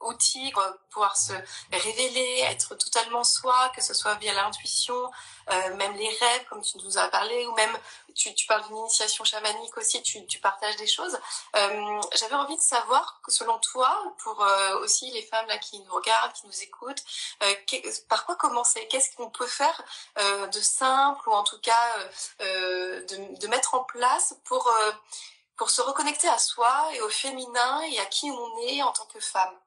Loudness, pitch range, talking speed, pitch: -25 LUFS, 210-280 Hz, 200 wpm, 235 Hz